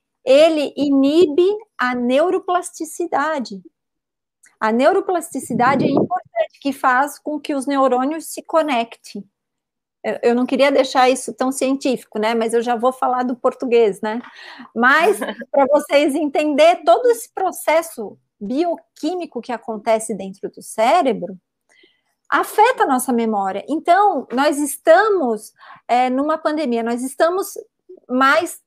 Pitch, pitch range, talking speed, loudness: 275 Hz, 240-330 Hz, 120 wpm, -18 LUFS